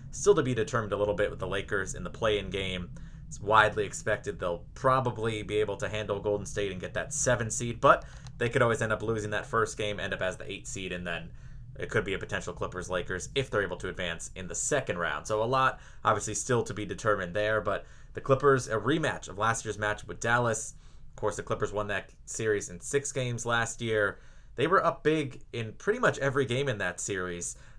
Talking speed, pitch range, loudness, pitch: 235 wpm, 105-130 Hz, -30 LUFS, 110 Hz